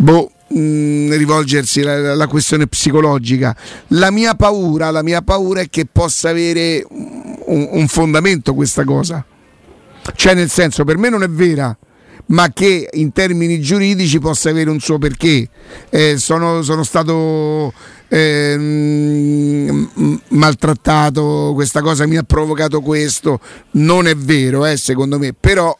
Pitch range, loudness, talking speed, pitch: 145-165 Hz, -13 LUFS, 135 wpm, 155 Hz